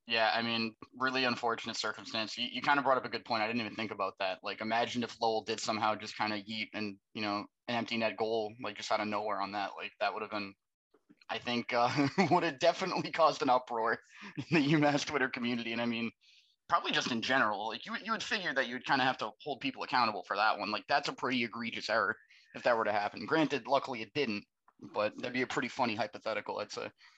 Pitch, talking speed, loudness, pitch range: 115 Hz, 245 wpm, -33 LUFS, 110-135 Hz